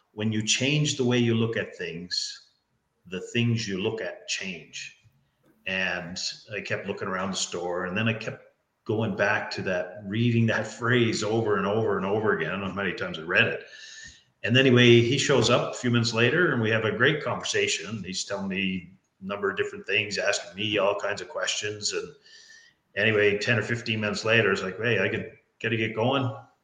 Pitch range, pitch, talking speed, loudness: 105-125 Hz, 115 Hz, 215 wpm, -25 LUFS